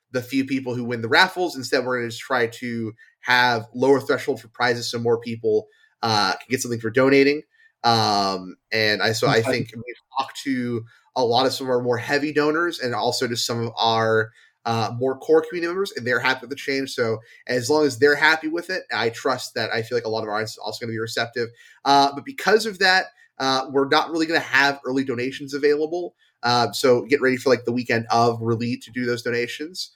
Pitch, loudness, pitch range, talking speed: 125 Hz, -22 LUFS, 115-140 Hz, 230 wpm